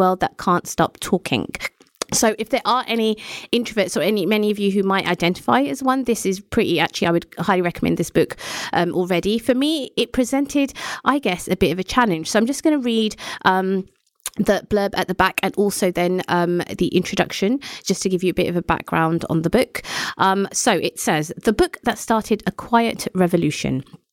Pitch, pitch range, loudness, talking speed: 200 Hz, 180-235 Hz, -20 LUFS, 210 wpm